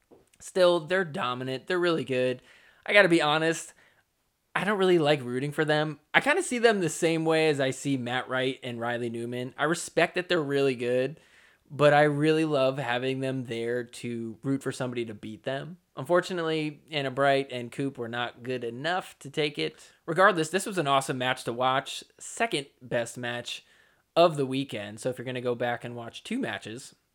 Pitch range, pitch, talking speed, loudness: 125-160 Hz, 135 Hz, 195 wpm, -27 LUFS